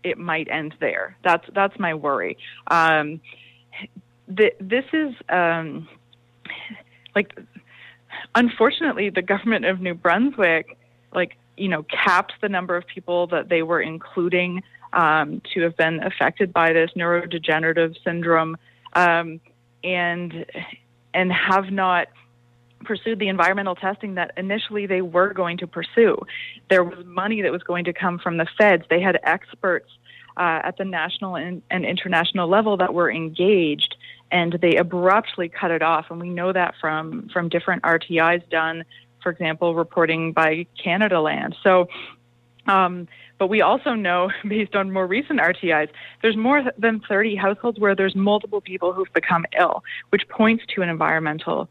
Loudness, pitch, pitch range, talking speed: -21 LUFS, 180 Hz, 165-195 Hz, 150 wpm